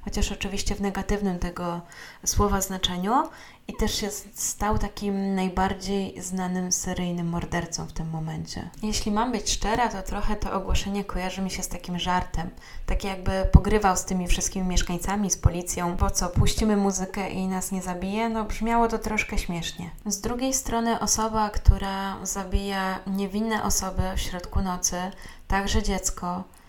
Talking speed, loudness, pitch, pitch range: 155 wpm, -27 LUFS, 195 Hz, 180-205 Hz